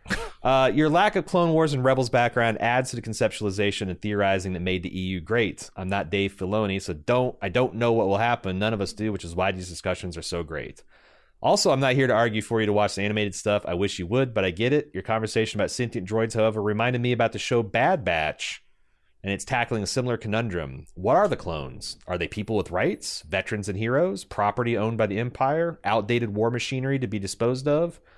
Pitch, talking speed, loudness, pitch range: 110 Hz, 230 wpm, -25 LUFS, 100-120 Hz